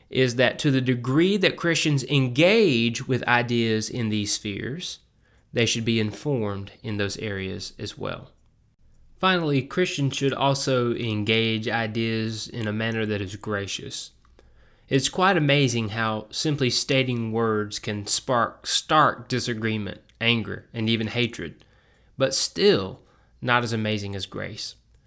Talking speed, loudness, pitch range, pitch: 135 wpm, -24 LUFS, 105-130 Hz, 115 Hz